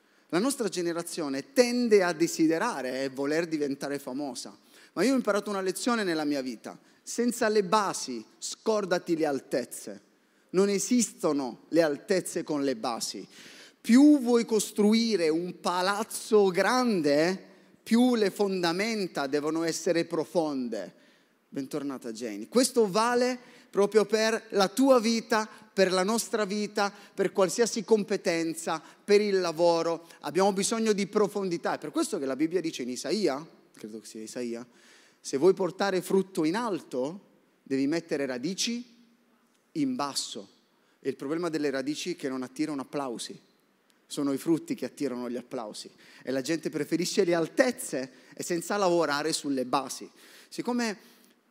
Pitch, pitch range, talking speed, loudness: 185 Hz, 150-220 Hz, 140 wpm, -28 LUFS